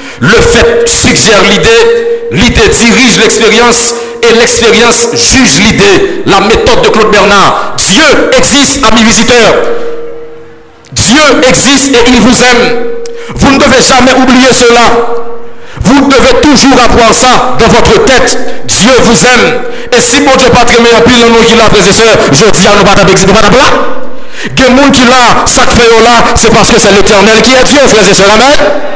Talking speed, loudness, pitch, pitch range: 160 wpm, -2 LUFS, 245 Hz, 230-275 Hz